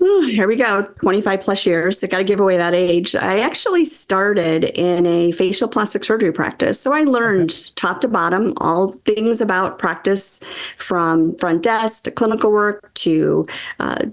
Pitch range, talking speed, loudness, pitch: 175-220 Hz, 170 wpm, -17 LUFS, 195 Hz